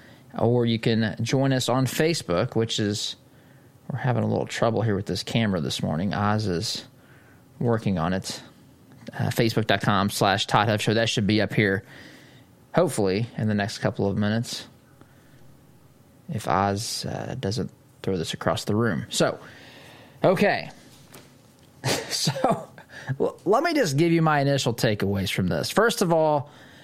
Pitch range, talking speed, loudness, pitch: 105-135 Hz, 150 wpm, -24 LUFS, 120 Hz